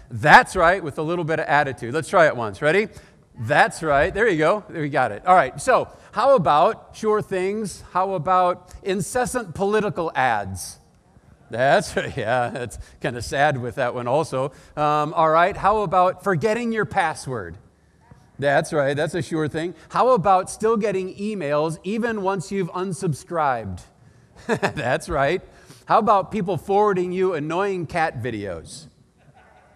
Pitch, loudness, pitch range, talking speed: 175 Hz, -21 LUFS, 145-195 Hz, 155 wpm